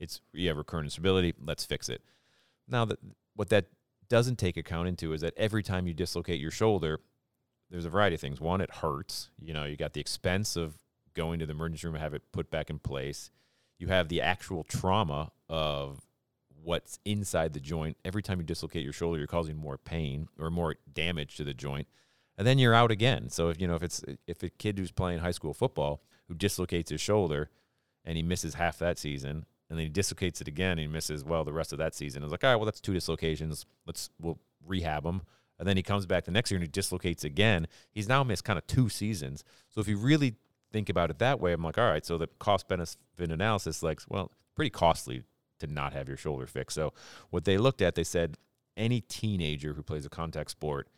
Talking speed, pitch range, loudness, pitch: 230 wpm, 75-100 Hz, -32 LUFS, 85 Hz